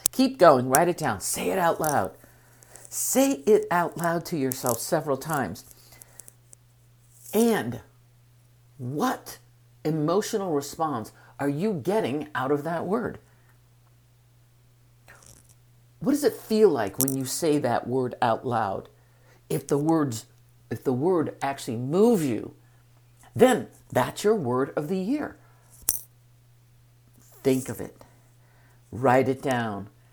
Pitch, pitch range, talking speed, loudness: 125 Hz, 120-155 Hz, 125 wpm, -25 LUFS